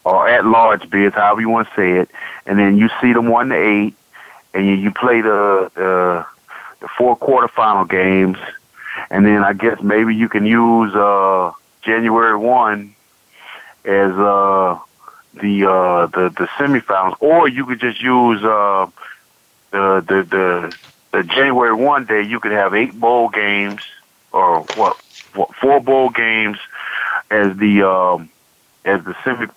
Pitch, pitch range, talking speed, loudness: 105 Hz, 95-115 Hz, 155 wpm, -15 LUFS